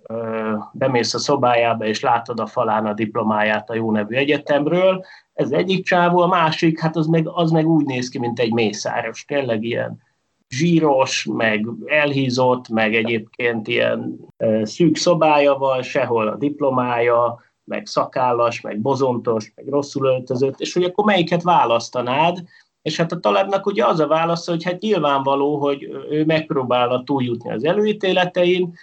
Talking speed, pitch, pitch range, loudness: 150 wpm, 135 Hz, 115-165 Hz, -19 LUFS